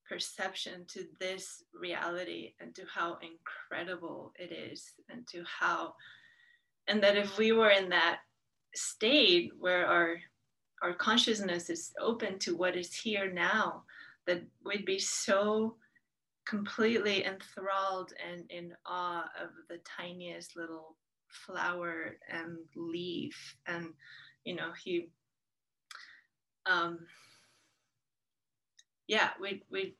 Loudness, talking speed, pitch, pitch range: -33 LUFS, 110 wpm, 185 Hz, 170-205 Hz